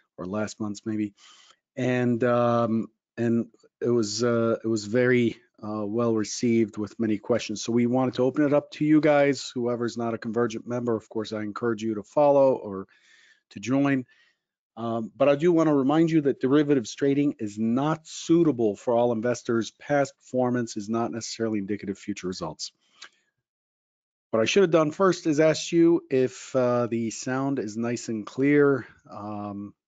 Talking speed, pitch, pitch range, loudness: 175 wpm, 120 Hz, 110-140 Hz, -25 LUFS